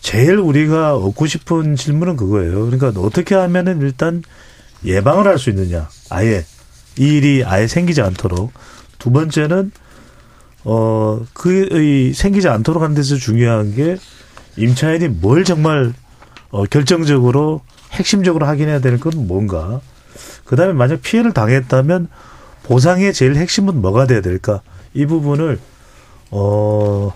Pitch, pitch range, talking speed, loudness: 135 Hz, 110-165 Hz, 285 characters per minute, -15 LUFS